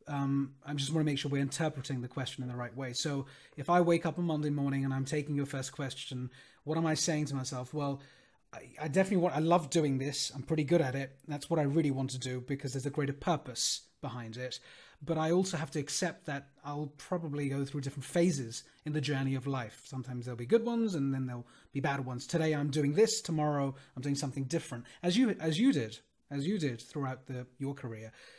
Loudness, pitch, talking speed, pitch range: -34 LUFS, 140 Hz, 240 wpm, 135-155 Hz